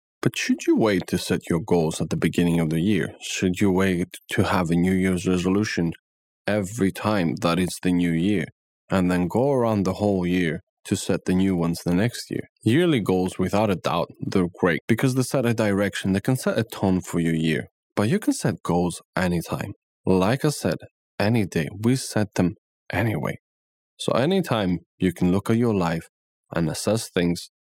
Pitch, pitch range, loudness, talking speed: 95 Hz, 85-110 Hz, -23 LUFS, 200 wpm